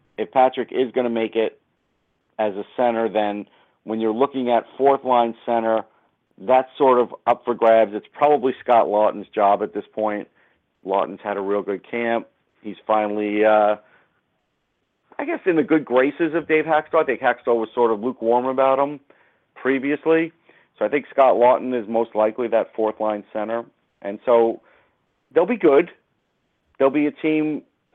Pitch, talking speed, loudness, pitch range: 115 Hz, 175 wpm, -20 LUFS, 110-135 Hz